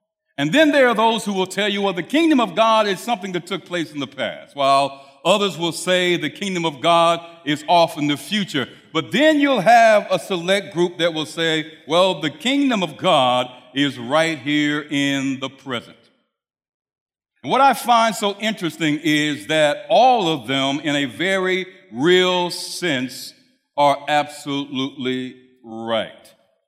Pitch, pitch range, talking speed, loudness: 170 Hz, 145-200 Hz, 170 wpm, -19 LUFS